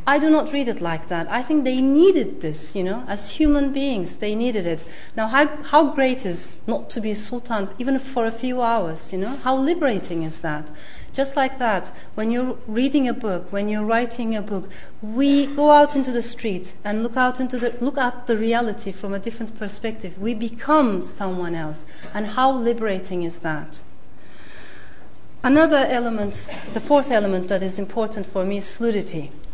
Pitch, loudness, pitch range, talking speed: 225 Hz, -22 LUFS, 195-260 Hz, 190 wpm